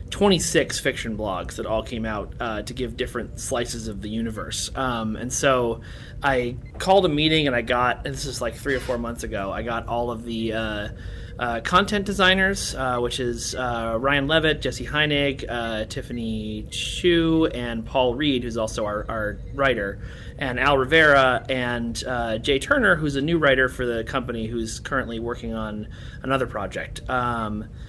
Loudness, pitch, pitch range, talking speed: -23 LUFS, 120 Hz, 115-135 Hz, 180 wpm